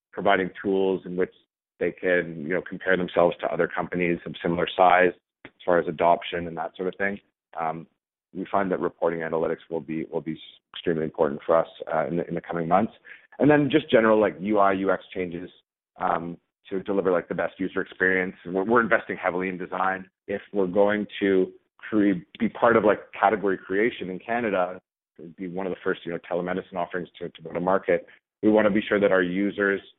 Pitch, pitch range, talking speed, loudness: 95 Hz, 85-100 Hz, 205 wpm, -25 LUFS